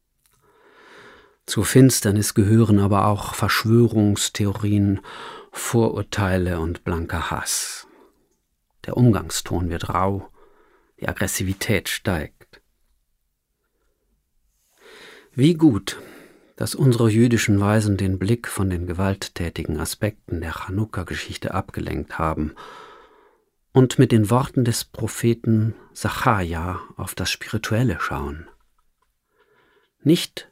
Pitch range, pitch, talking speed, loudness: 95-130 Hz, 105 Hz, 90 wpm, -21 LUFS